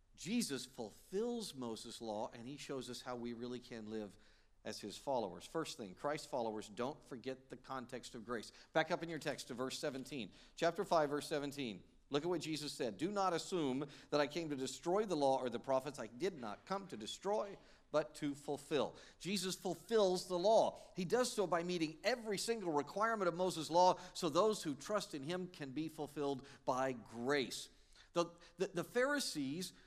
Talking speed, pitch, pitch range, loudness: 190 wpm, 155 Hz, 130-180 Hz, -40 LUFS